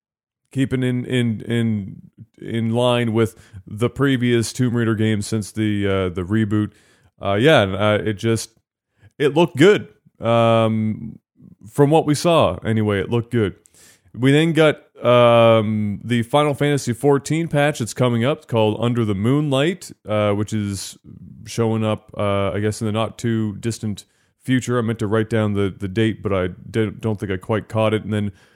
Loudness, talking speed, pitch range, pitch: -19 LUFS, 175 wpm, 105-125 Hz, 110 Hz